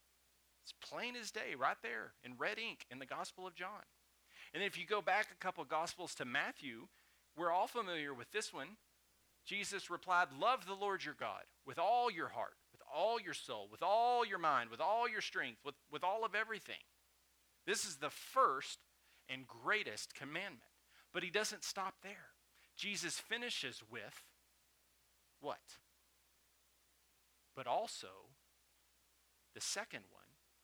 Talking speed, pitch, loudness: 155 wpm, 155 Hz, -41 LUFS